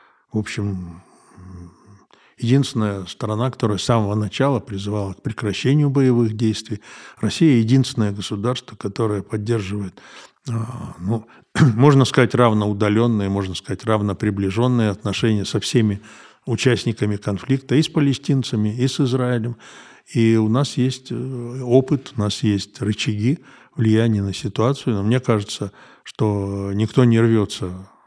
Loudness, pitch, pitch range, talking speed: -20 LUFS, 110 Hz, 105-125 Hz, 120 wpm